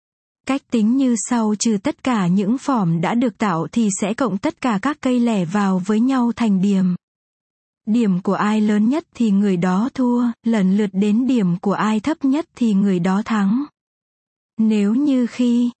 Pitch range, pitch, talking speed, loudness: 200-250 Hz, 220 Hz, 185 wpm, -19 LUFS